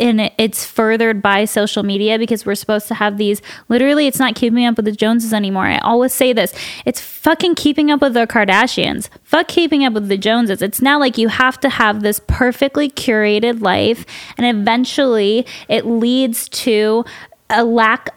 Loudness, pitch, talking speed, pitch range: -15 LUFS, 230 Hz, 190 wpm, 215-255 Hz